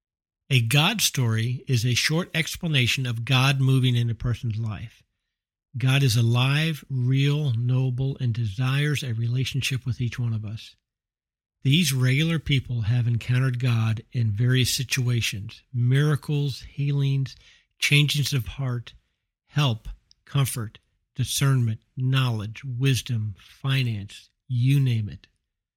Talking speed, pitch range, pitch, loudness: 120 wpm, 115-135 Hz, 125 Hz, -24 LUFS